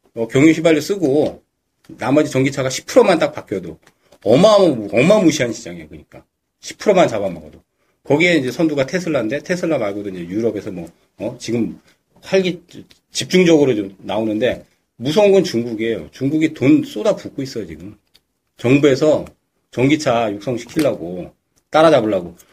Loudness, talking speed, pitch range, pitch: -16 LUFS, 335 characters per minute, 115-175 Hz, 145 Hz